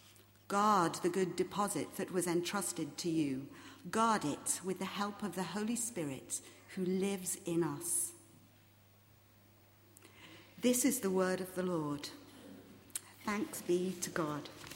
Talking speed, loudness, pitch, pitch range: 135 wpm, -36 LUFS, 175 Hz, 130-190 Hz